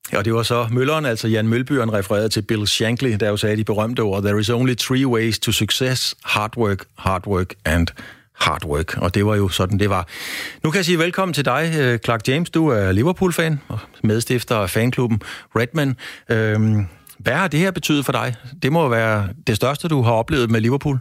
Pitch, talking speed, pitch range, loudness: 115 Hz, 210 wpm, 105-135 Hz, -19 LUFS